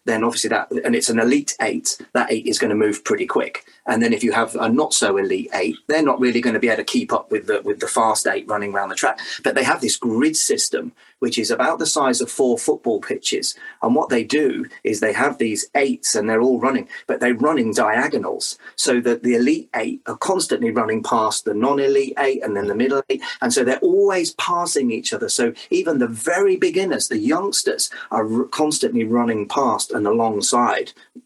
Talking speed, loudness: 225 wpm, -19 LUFS